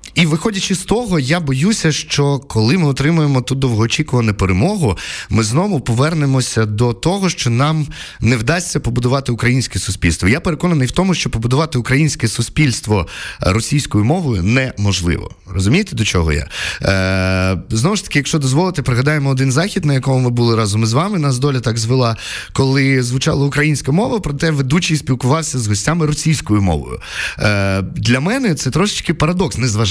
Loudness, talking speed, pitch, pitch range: -15 LUFS, 155 wpm, 130 Hz, 115-155 Hz